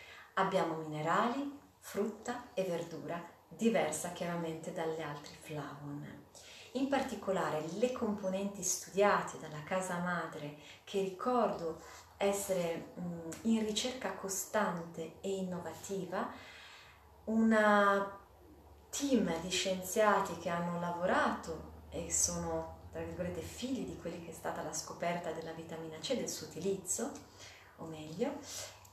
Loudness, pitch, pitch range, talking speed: -36 LUFS, 175 Hz, 160-205 Hz, 110 wpm